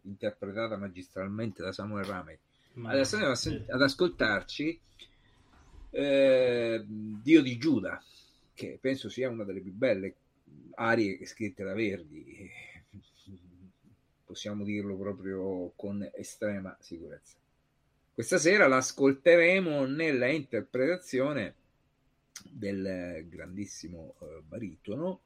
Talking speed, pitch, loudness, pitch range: 95 wpm, 105 Hz, -30 LUFS, 95-130 Hz